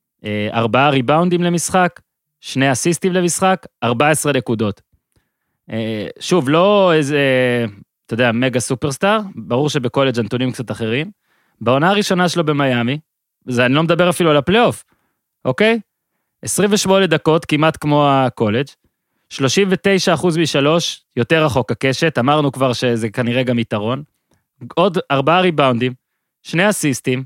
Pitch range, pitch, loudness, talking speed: 125-175 Hz, 145 Hz, -16 LUFS, 115 wpm